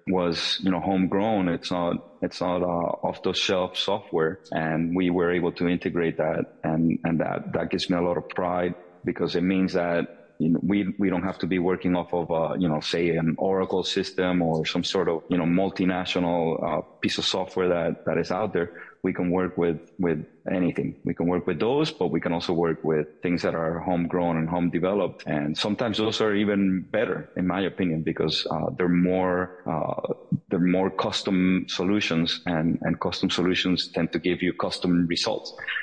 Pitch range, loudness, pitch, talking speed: 85-95 Hz, -25 LUFS, 90 Hz, 200 wpm